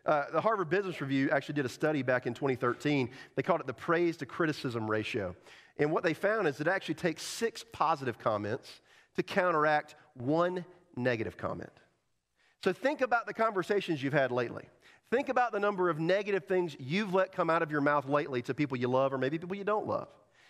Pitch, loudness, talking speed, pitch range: 160 Hz, -32 LUFS, 205 wpm, 135-190 Hz